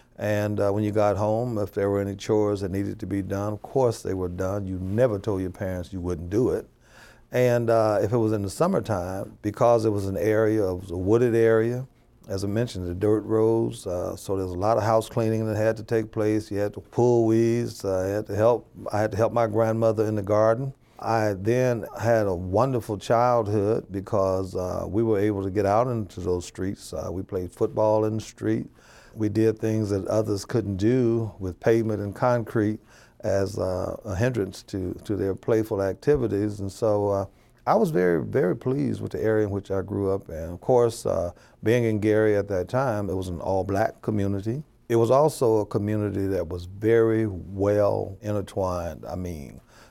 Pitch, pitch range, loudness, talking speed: 105 Hz, 95-115 Hz, -25 LUFS, 210 wpm